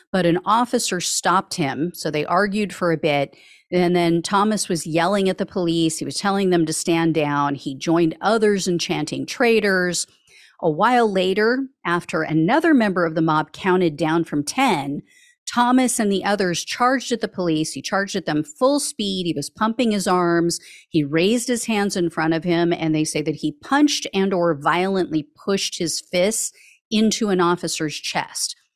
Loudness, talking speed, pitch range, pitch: -20 LUFS, 185 wpm, 165-210 Hz, 180 Hz